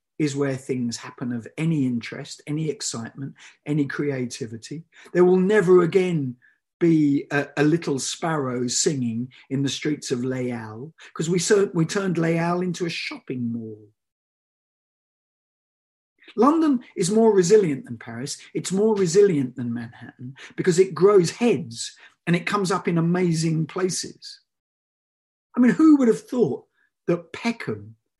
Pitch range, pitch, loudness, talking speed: 130-190 Hz, 160 Hz, -22 LUFS, 140 wpm